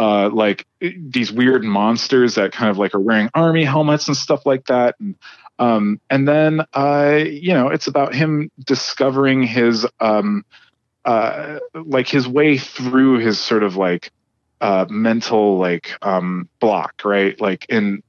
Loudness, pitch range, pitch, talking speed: -17 LUFS, 105-145 Hz, 125 Hz, 160 wpm